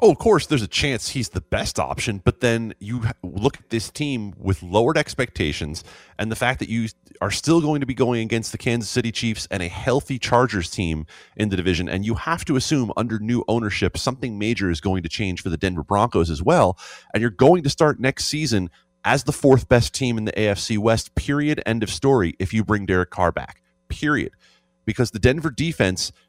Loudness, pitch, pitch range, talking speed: -22 LUFS, 110 Hz, 95-125 Hz, 215 wpm